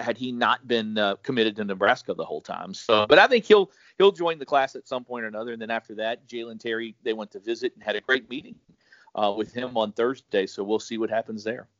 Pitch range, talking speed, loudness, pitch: 110-130 Hz, 260 wpm, -25 LUFS, 115 Hz